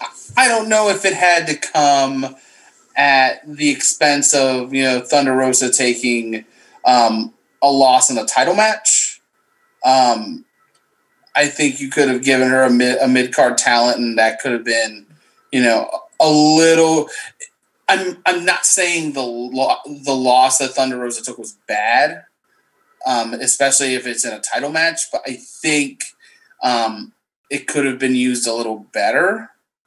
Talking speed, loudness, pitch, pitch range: 160 wpm, -15 LUFS, 135 Hz, 125-175 Hz